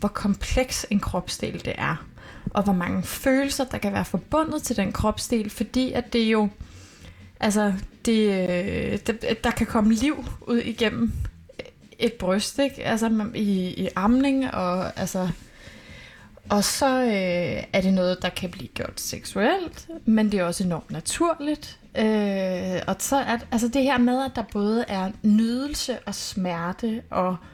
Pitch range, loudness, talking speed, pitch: 185-245 Hz, -24 LUFS, 155 wpm, 215 Hz